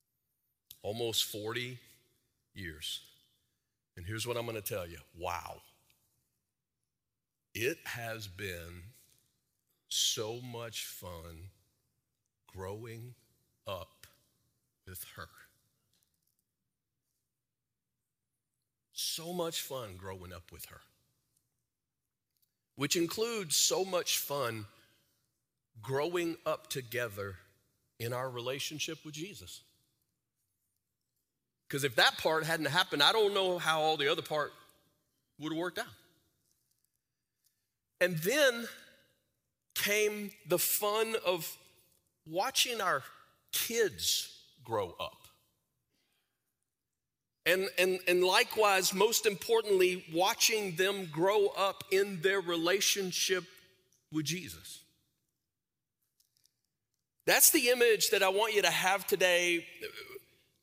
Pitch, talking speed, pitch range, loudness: 135 Hz, 95 wpm, 115-185 Hz, -31 LUFS